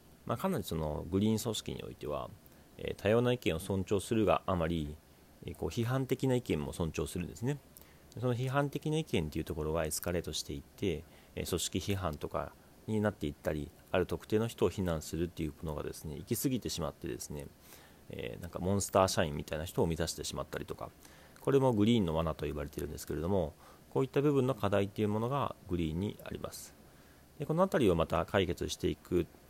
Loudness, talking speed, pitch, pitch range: -34 LUFS, 445 characters per minute, 85 Hz, 75-110 Hz